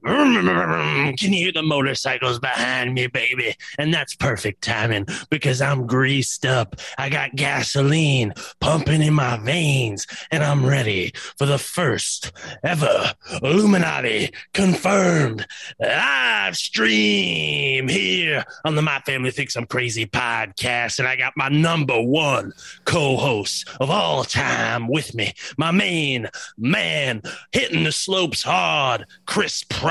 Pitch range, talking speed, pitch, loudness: 120-150 Hz, 130 wpm, 135 Hz, -20 LUFS